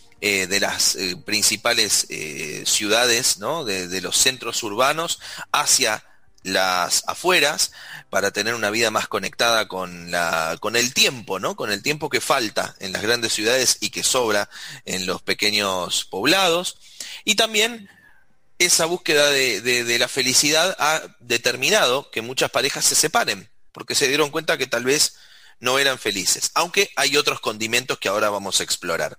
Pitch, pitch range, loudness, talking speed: 120 Hz, 100-145 Hz, -19 LUFS, 160 wpm